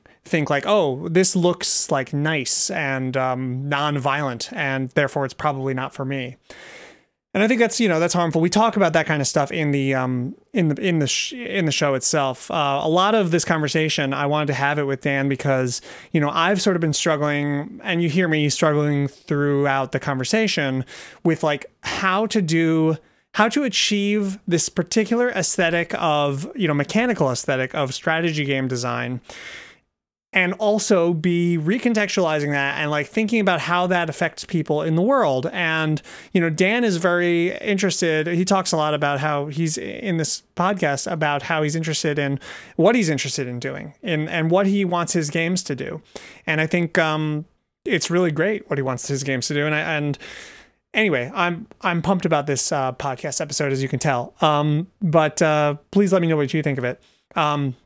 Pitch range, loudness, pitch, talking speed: 145-180 Hz, -21 LUFS, 155 Hz, 195 wpm